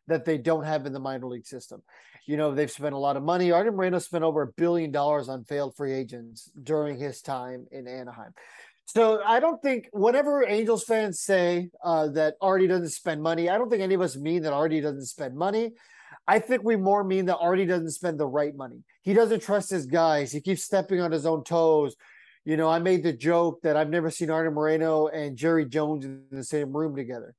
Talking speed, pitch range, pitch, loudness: 225 wpm, 145-185 Hz, 160 Hz, -26 LUFS